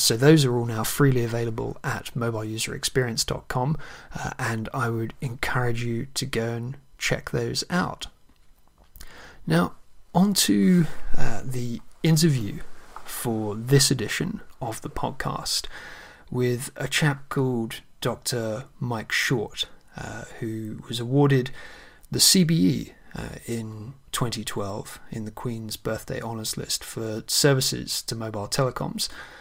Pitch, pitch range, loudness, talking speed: 120 Hz, 115-140 Hz, -25 LUFS, 120 wpm